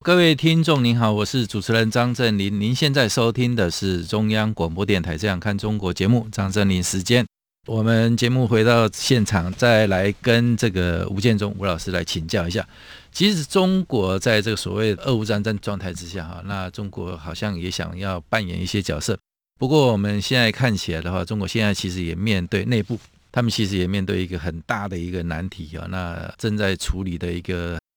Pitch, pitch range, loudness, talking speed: 100 Hz, 90-115 Hz, -21 LUFS, 305 characters per minute